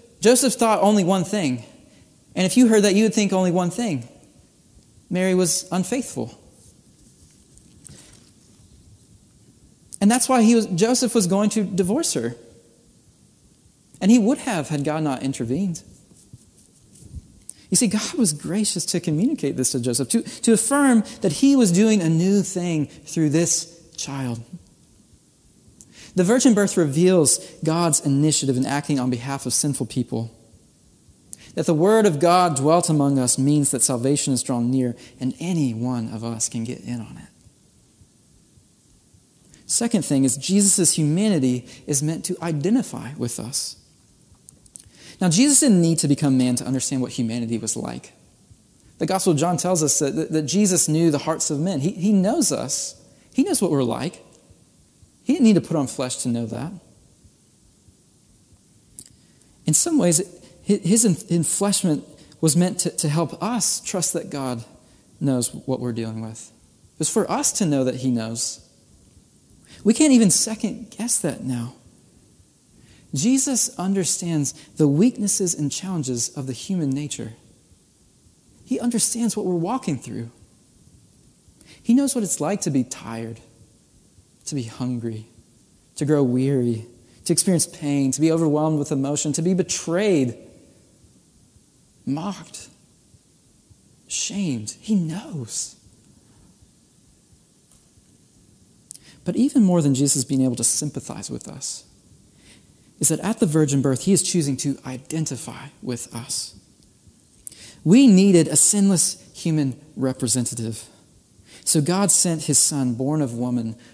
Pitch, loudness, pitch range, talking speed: 155 Hz, -20 LUFS, 130-195 Hz, 140 wpm